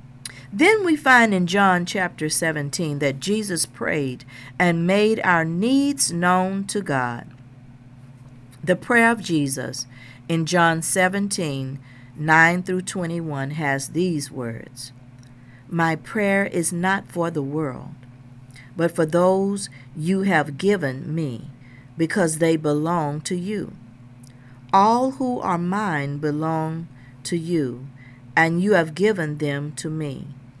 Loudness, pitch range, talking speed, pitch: -21 LUFS, 130-185 Hz, 120 wpm, 160 Hz